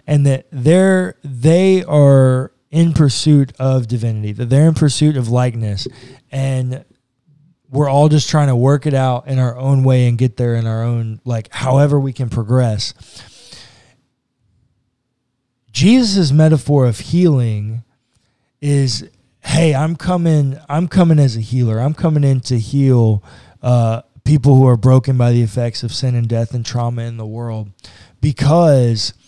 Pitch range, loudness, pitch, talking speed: 120-145 Hz, -14 LUFS, 130 Hz, 155 wpm